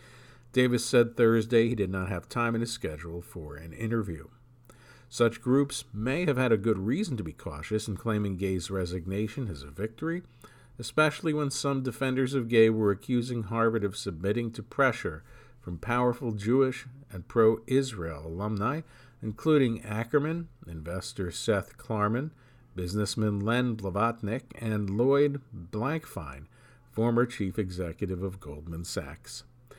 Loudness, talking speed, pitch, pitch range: -29 LUFS, 140 wpm, 115 Hz, 100-125 Hz